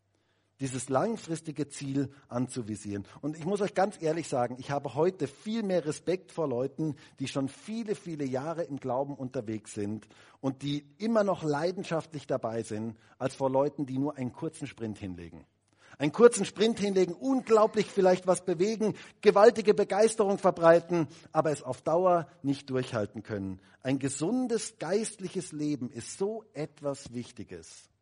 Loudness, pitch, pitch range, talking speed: -30 LUFS, 145 Hz, 125-185 Hz, 150 wpm